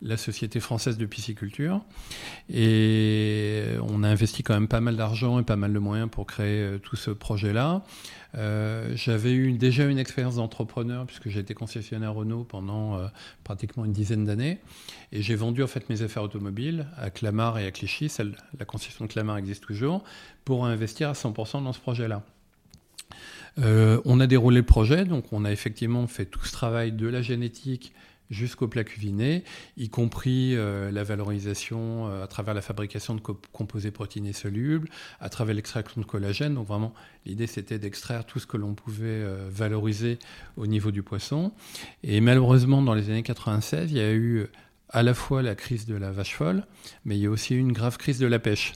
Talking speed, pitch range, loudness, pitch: 190 wpm, 105-125 Hz, -27 LUFS, 110 Hz